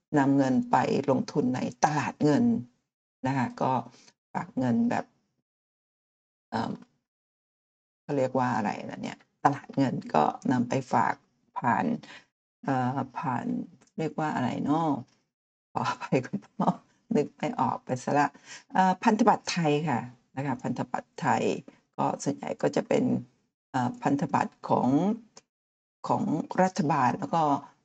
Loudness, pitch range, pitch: -28 LUFS, 125-185 Hz, 140 Hz